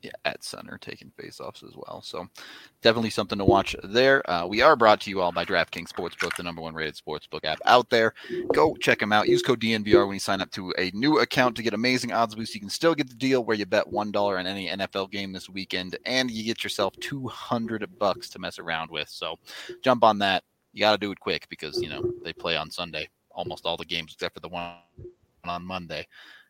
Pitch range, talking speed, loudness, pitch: 95-120 Hz, 240 wpm, -25 LUFS, 105 Hz